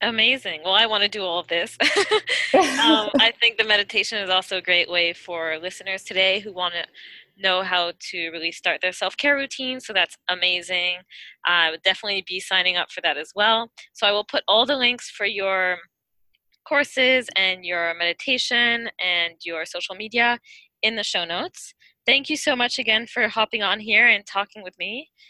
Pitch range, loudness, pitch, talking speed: 180-240 Hz, -21 LUFS, 205 Hz, 195 wpm